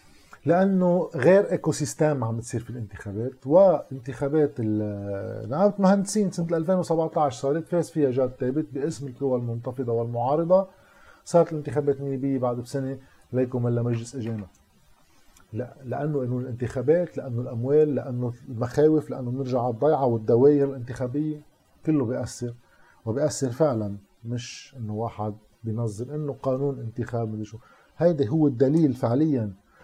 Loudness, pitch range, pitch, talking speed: -25 LUFS, 115-150 Hz, 130 Hz, 125 wpm